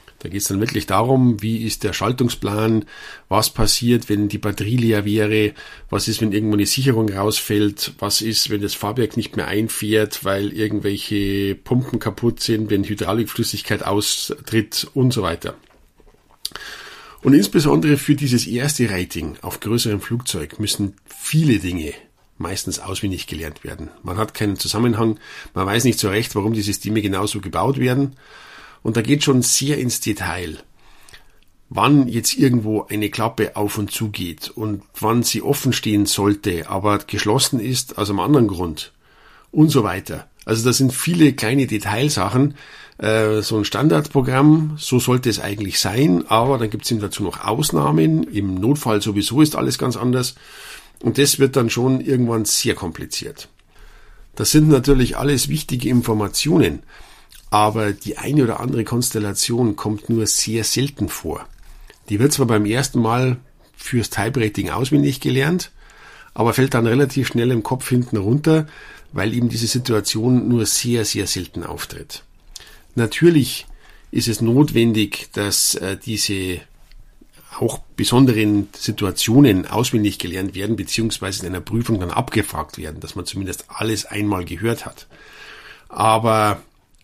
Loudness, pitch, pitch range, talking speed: -19 LUFS, 110 Hz, 105-125 Hz, 150 wpm